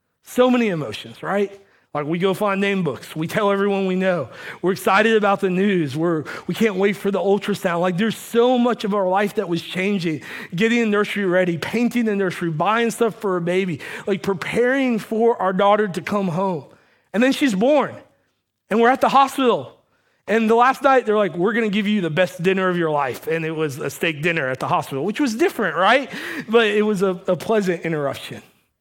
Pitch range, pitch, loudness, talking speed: 180-225 Hz, 200 Hz, -20 LUFS, 220 wpm